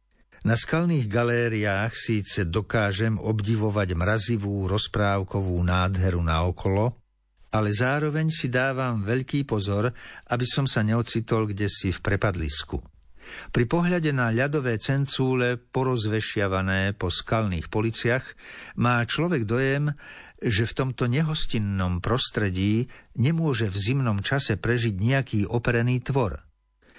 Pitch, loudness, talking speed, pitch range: 115 Hz, -25 LUFS, 110 wpm, 100-125 Hz